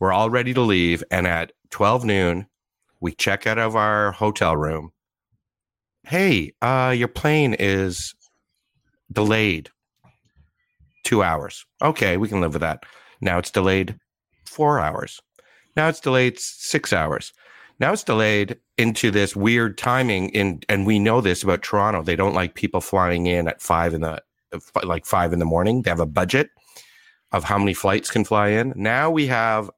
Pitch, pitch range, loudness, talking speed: 105 Hz, 90-120 Hz, -21 LUFS, 165 wpm